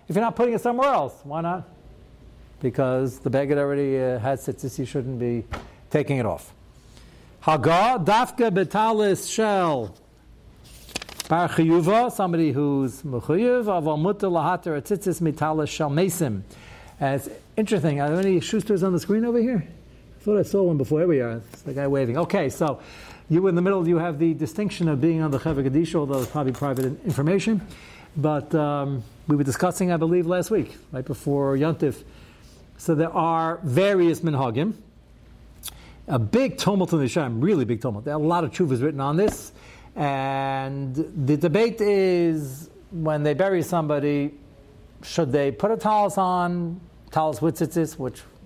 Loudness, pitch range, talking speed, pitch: -23 LUFS, 140-180 Hz, 165 wpm, 160 Hz